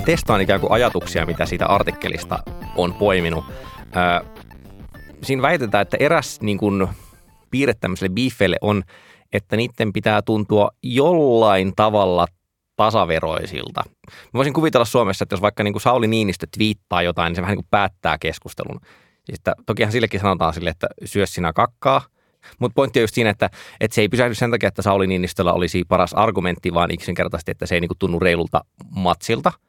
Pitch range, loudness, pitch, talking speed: 90-110 Hz, -19 LUFS, 100 Hz, 165 wpm